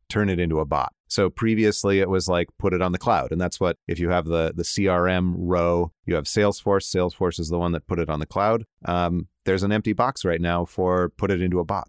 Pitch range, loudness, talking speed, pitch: 85-100 Hz, -23 LUFS, 255 wpm, 90 Hz